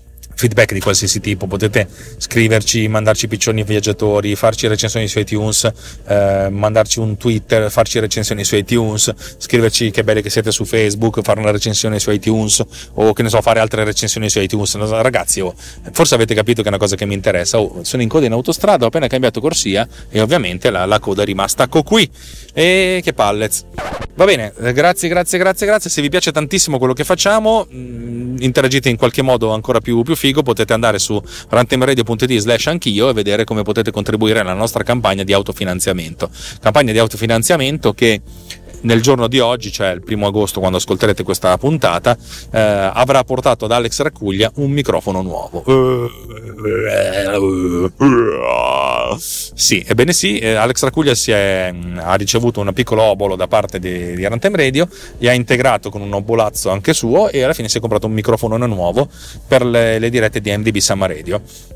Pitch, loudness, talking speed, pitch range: 110 Hz, -14 LUFS, 175 wpm, 105-125 Hz